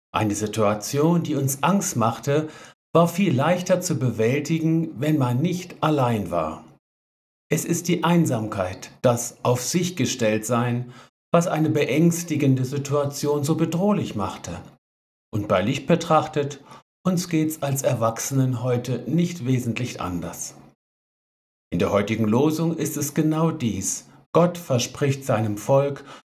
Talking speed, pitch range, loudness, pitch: 130 wpm, 120-160 Hz, -23 LUFS, 140 Hz